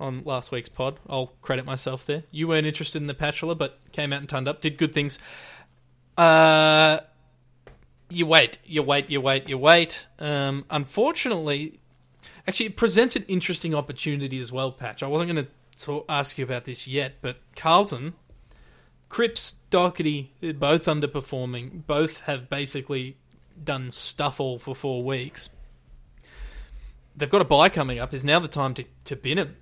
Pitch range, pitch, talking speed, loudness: 130-155 Hz, 145 Hz, 165 wpm, -24 LUFS